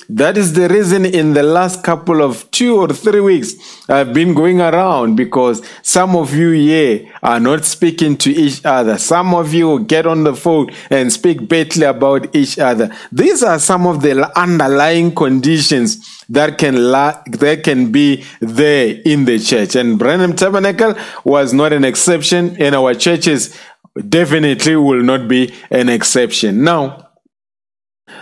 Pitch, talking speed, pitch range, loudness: 160 Hz, 160 wpm, 140-180 Hz, -12 LUFS